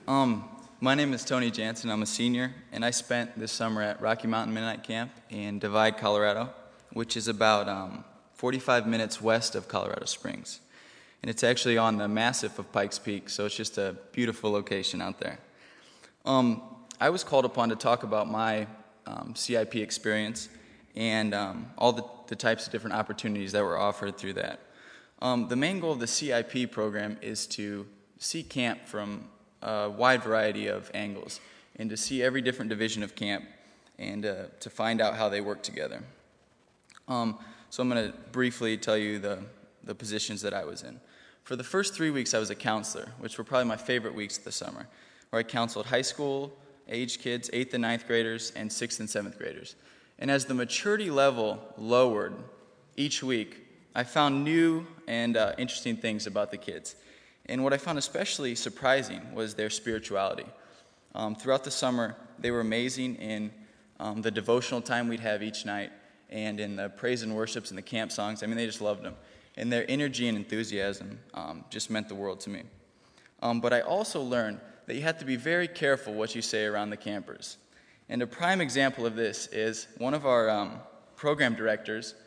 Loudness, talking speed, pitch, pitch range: -30 LUFS, 190 wpm, 115 Hz, 105-125 Hz